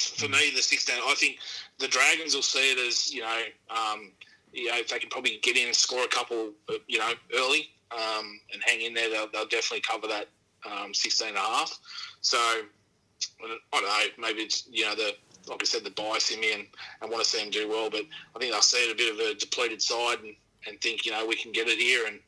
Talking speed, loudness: 250 wpm, -26 LUFS